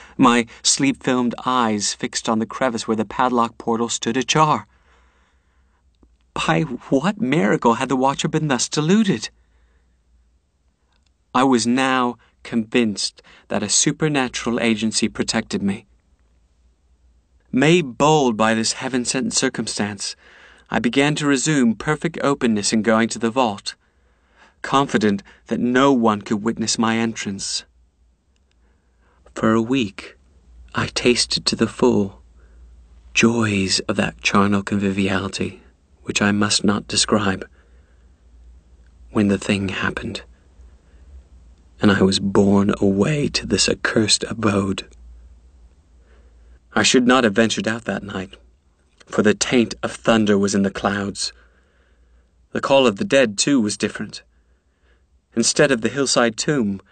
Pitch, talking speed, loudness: 100 Hz, 125 wpm, -19 LUFS